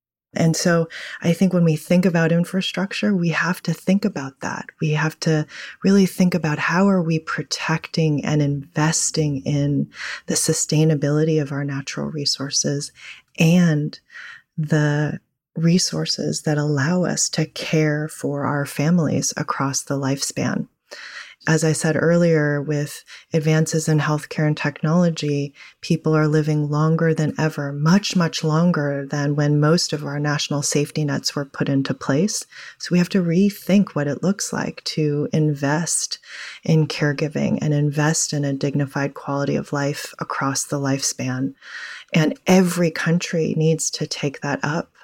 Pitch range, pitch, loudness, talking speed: 145-170 Hz, 155 Hz, -20 LUFS, 150 wpm